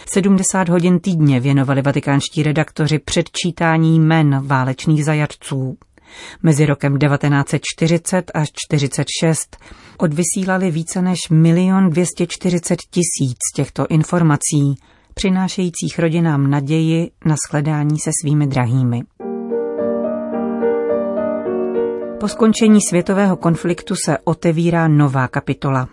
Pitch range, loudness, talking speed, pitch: 140-175 Hz, -17 LUFS, 90 wpm, 155 Hz